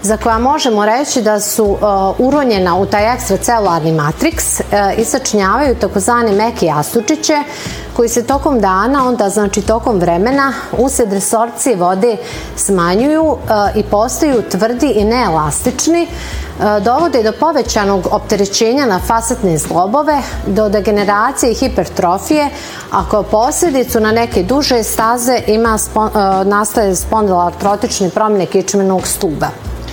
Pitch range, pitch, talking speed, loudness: 200-250 Hz, 220 Hz, 110 wpm, -13 LUFS